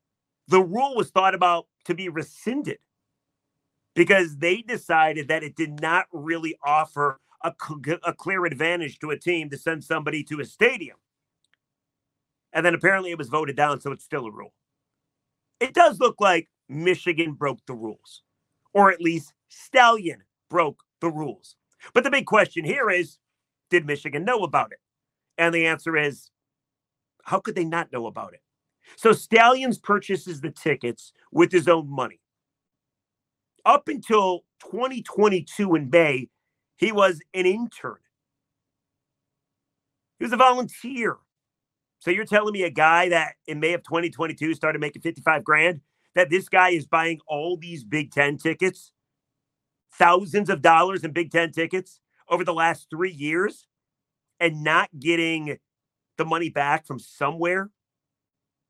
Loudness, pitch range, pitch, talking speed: -22 LUFS, 145-180 Hz, 165 Hz, 150 wpm